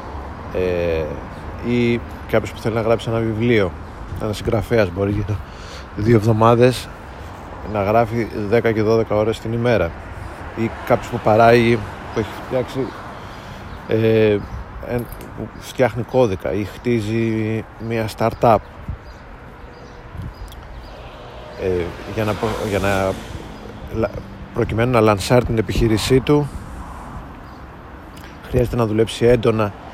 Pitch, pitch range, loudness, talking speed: 110 Hz, 95-115 Hz, -19 LUFS, 110 wpm